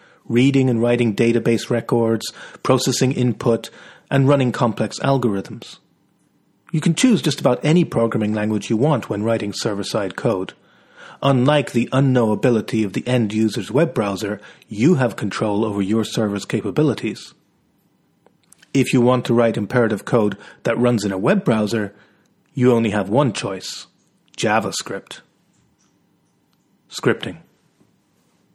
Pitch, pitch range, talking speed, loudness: 120 Hz, 110-130 Hz, 130 wpm, -19 LUFS